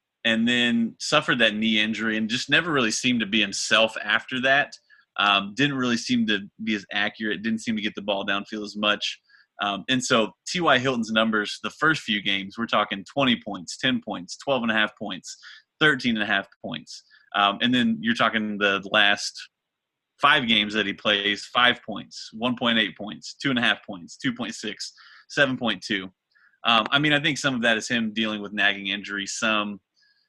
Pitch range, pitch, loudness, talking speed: 105-120 Hz, 110 Hz, -23 LUFS, 190 wpm